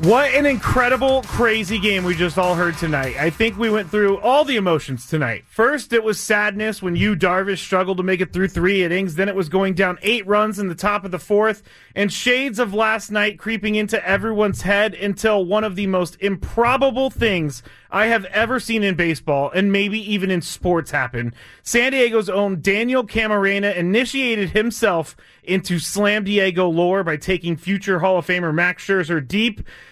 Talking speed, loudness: 190 wpm, -19 LUFS